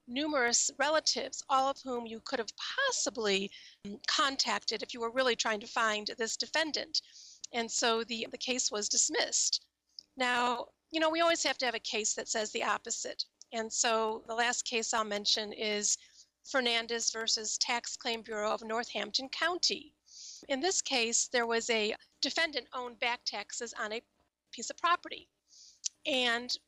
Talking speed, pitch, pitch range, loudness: 160 wpm, 235 Hz, 225-270 Hz, -32 LUFS